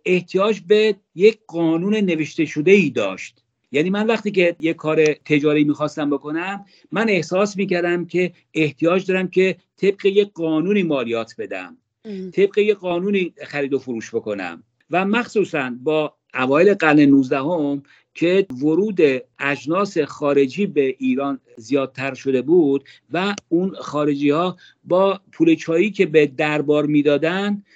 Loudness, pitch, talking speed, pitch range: -19 LUFS, 165 Hz, 135 wpm, 145-195 Hz